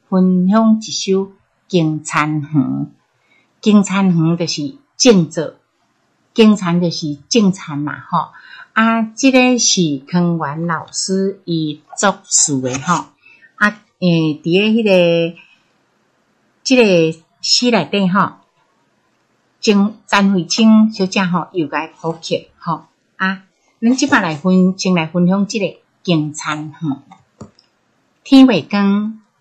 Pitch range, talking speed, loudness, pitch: 160-210 Hz, 165 characters per minute, -15 LUFS, 185 Hz